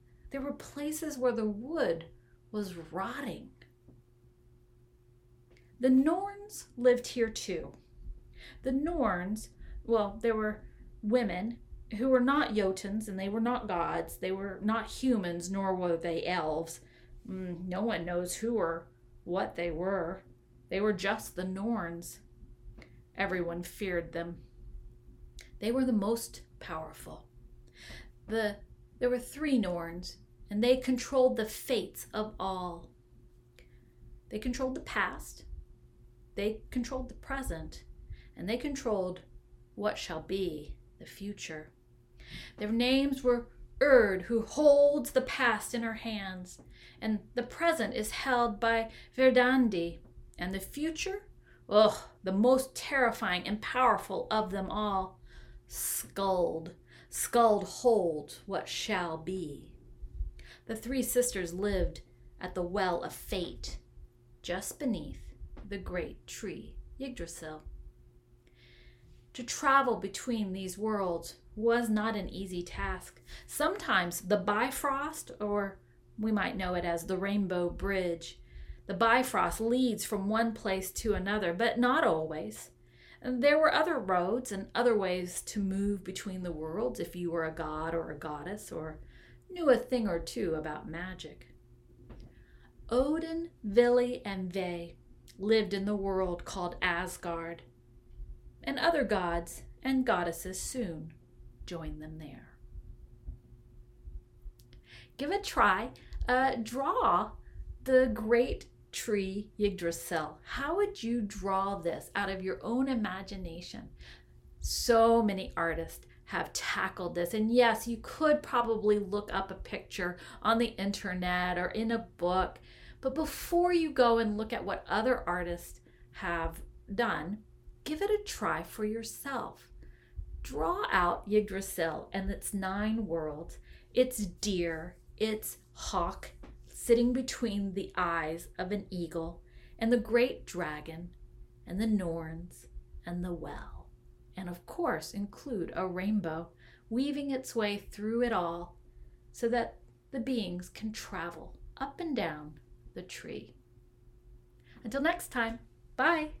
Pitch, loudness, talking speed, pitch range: 195 Hz, -32 LUFS, 125 wpm, 165-235 Hz